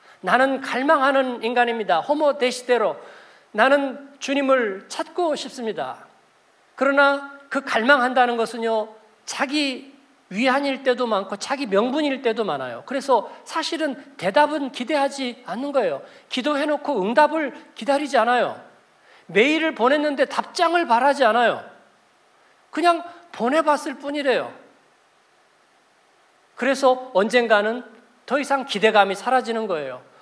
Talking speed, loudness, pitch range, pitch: 275 characters per minute, -21 LUFS, 245-295 Hz, 270 Hz